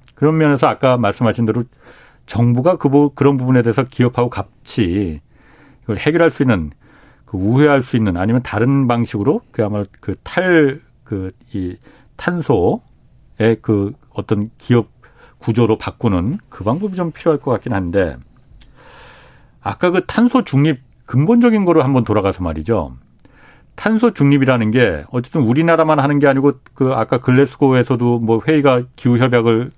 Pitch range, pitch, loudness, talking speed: 110-145 Hz, 125 Hz, -16 LUFS, 305 characters per minute